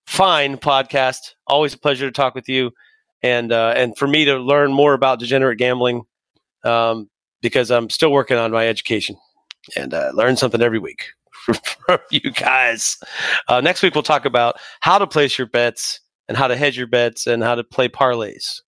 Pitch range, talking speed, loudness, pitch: 120-140 Hz, 190 wpm, -17 LUFS, 130 Hz